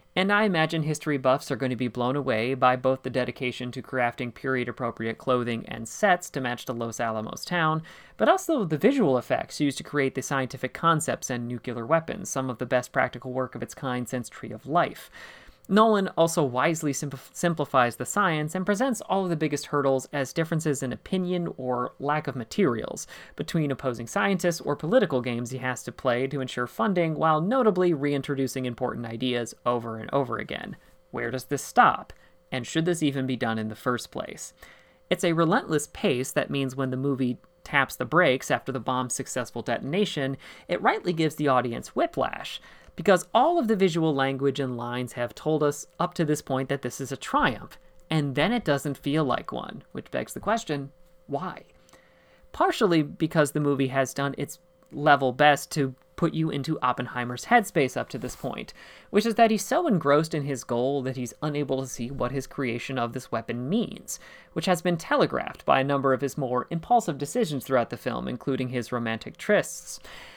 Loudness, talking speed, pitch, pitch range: -26 LUFS, 195 wpm, 135 Hz, 125-160 Hz